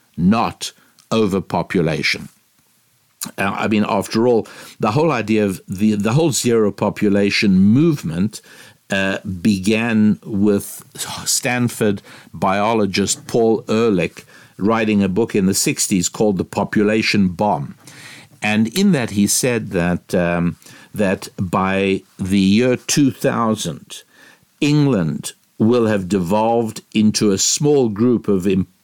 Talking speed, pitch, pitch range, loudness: 120 wpm, 105 Hz, 100-120 Hz, -17 LUFS